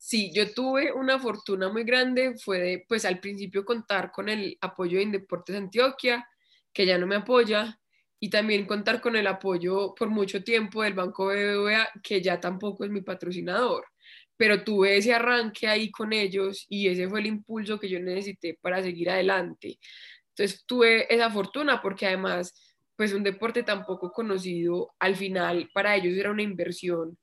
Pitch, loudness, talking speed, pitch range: 200 Hz, -26 LUFS, 175 wpm, 185-220 Hz